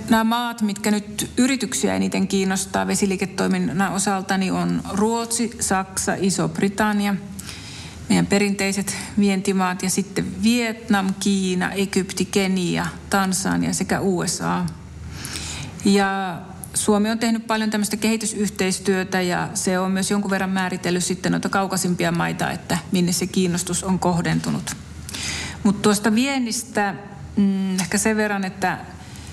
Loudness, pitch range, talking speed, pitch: -21 LUFS, 180-205 Hz, 120 wpm, 195 Hz